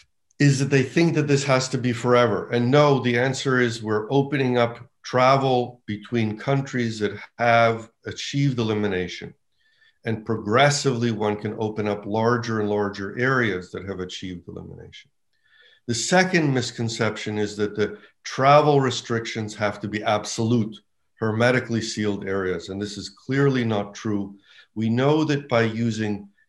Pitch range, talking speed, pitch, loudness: 105-130 Hz, 145 wpm, 115 Hz, -22 LUFS